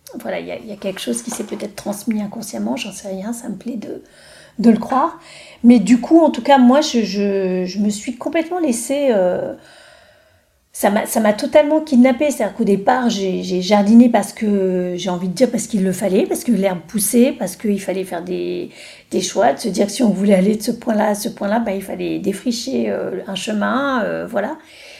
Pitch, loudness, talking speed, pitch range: 215 Hz, -17 LUFS, 220 wpm, 195-255 Hz